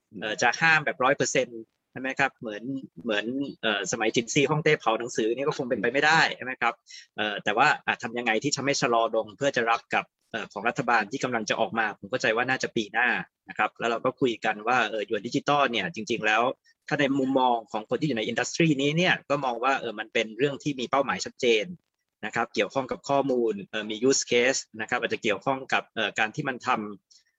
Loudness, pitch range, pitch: -26 LUFS, 115-140 Hz, 135 Hz